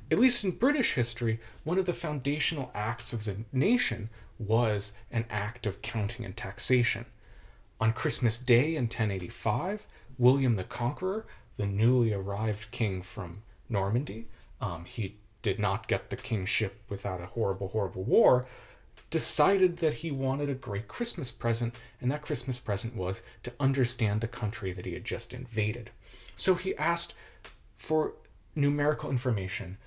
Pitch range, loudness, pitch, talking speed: 105-135 Hz, -29 LUFS, 120 Hz, 150 wpm